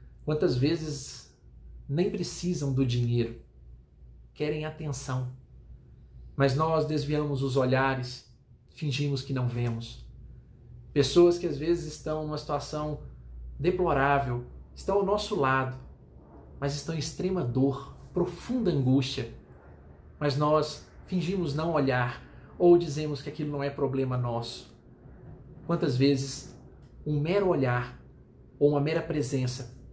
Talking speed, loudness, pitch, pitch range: 115 wpm, -29 LUFS, 140 Hz, 125-155 Hz